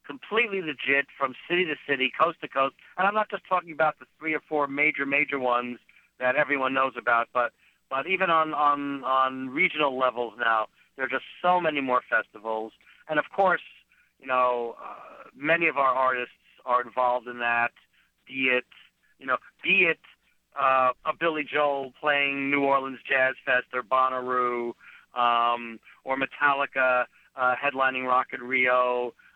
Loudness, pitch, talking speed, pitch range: -25 LUFS, 130 Hz, 165 wpm, 125-145 Hz